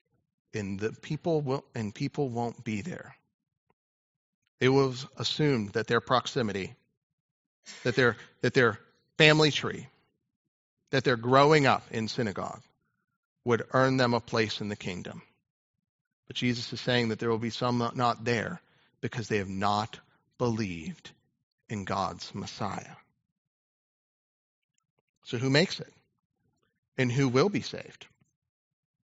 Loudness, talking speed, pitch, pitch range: -28 LUFS, 130 wpm, 125 Hz, 115-140 Hz